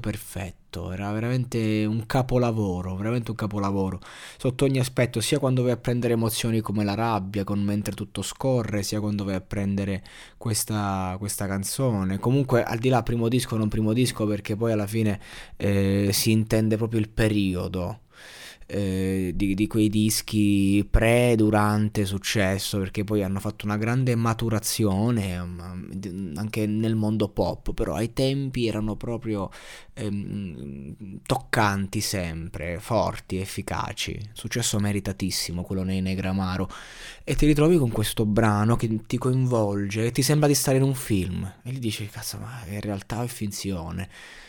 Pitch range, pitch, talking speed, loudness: 100-115 Hz, 105 Hz, 150 wpm, -25 LUFS